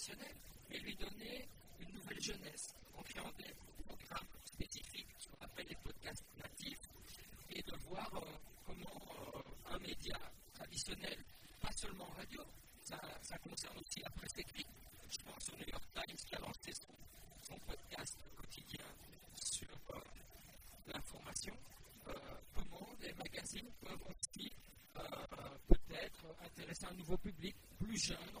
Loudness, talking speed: -49 LUFS, 135 wpm